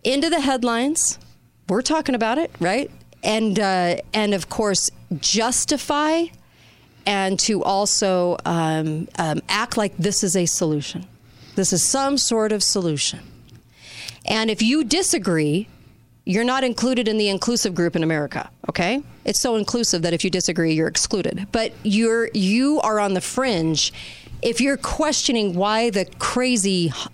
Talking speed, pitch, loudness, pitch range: 150 wpm, 205 Hz, -20 LUFS, 175-240 Hz